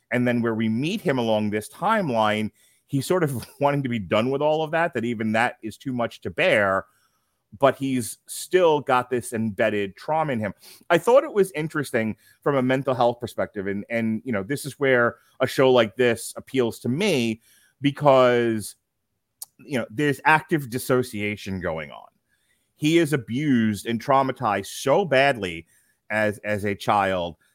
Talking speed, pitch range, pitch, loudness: 175 wpm, 110-140 Hz, 125 Hz, -23 LUFS